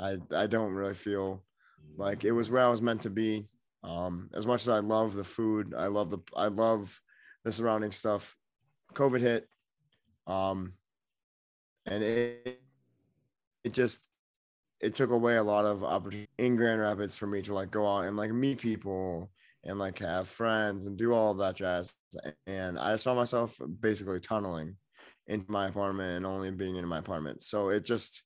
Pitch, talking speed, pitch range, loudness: 105 Hz, 180 wpm, 95-115 Hz, -32 LUFS